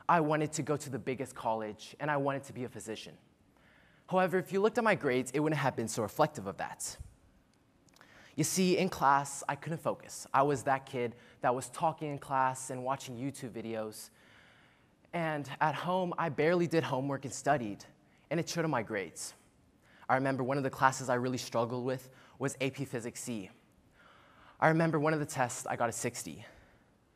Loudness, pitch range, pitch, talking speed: -33 LUFS, 125-155 Hz, 135 Hz, 195 wpm